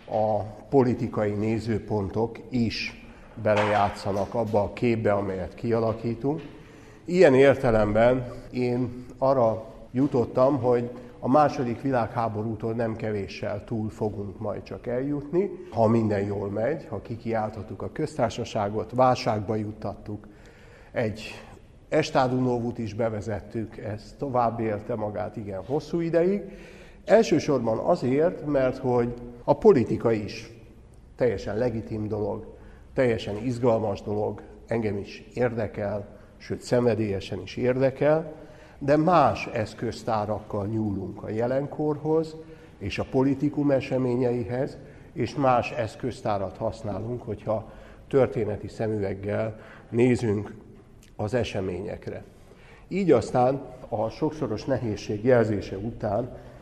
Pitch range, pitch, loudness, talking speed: 105-130 Hz, 115 Hz, -26 LUFS, 100 wpm